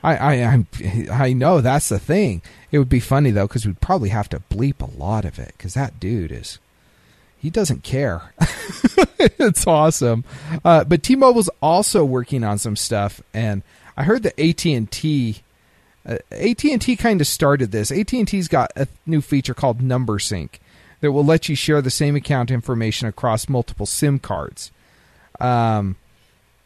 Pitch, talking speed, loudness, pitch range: 130 Hz, 160 wpm, -19 LUFS, 110-155 Hz